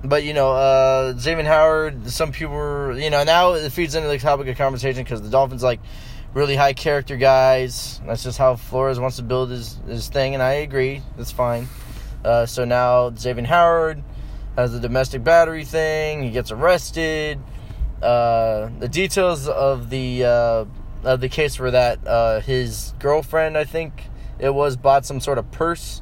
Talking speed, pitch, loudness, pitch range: 180 wpm, 130 Hz, -19 LUFS, 125-150 Hz